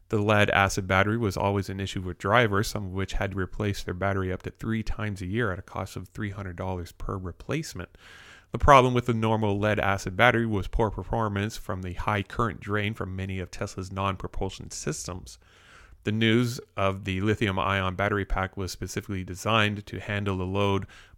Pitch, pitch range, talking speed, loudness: 100 Hz, 95-105 Hz, 195 wpm, -27 LUFS